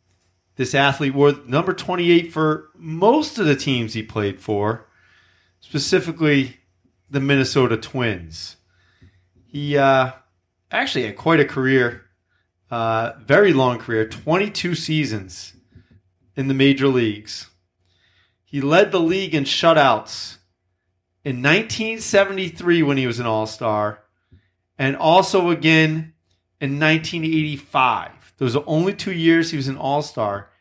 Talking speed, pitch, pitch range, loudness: 120 wpm, 130 Hz, 95-155 Hz, -19 LUFS